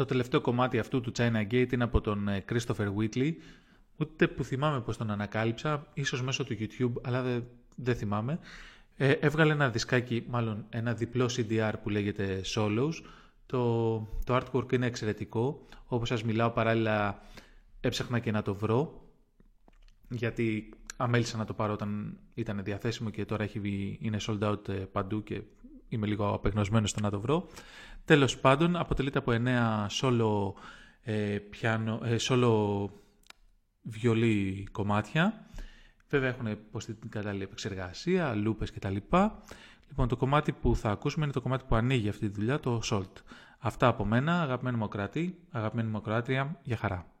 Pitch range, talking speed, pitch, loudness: 105-130 Hz, 155 wpm, 115 Hz, -31 LUFS